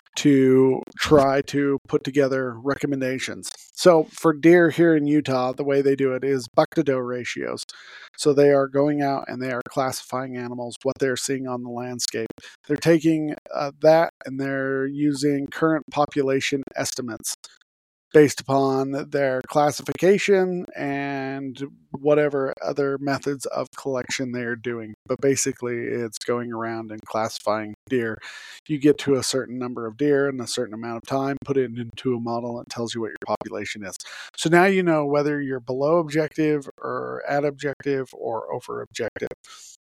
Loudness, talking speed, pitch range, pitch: -23 LUFS, 165 wpm, 125-145 Hz, 135 Hz